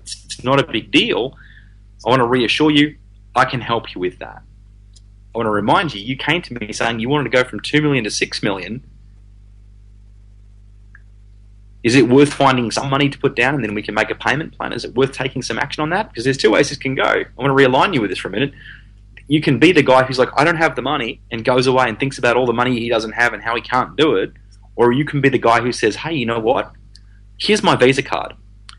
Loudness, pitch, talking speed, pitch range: -17 LUFS, 115 Hz, 260 wpm, 100-135 Hz